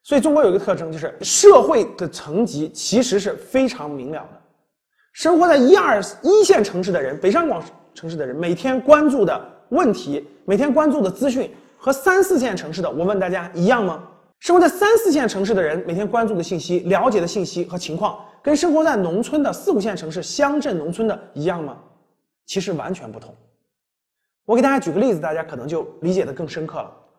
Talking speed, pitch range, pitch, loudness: 310 characters per minute, 175-285 Hz, 205 Hz, -18 LUFS